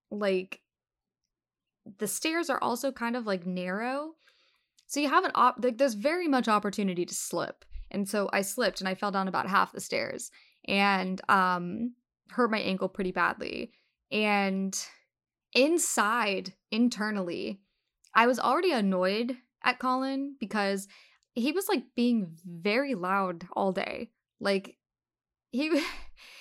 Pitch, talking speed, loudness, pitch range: 215 Hz, 135 wpm, -29 LUFS, 195-260 Hz